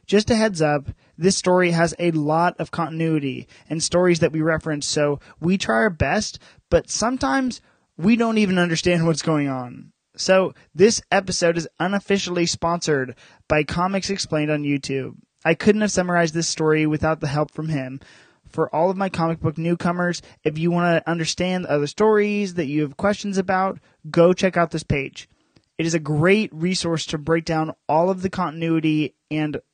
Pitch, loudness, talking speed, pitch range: 165 Hz, -21 LUFS, 180 wpm, 155-185 Hz